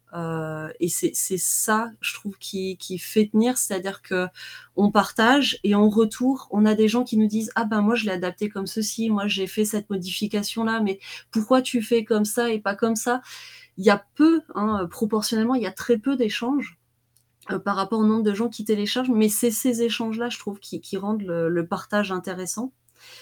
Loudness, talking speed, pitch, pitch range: -23 LUFS, 205 wpm, 215 Hz, 195-235 Hz